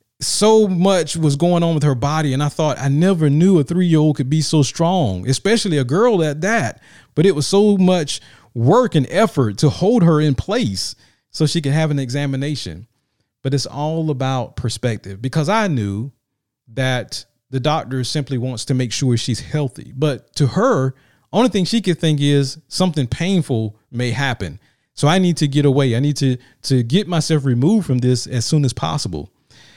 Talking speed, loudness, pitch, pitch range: 195 wpm, -17 LUFS, 140 Hz, 125-160 Hz